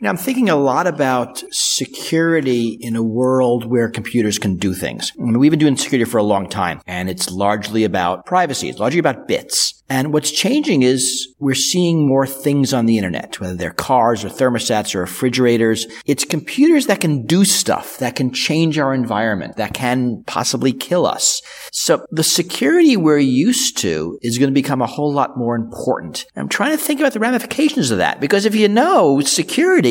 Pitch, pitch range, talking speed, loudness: 130 Hz, 115-165 Hz, 195 wpm, -16 LUFS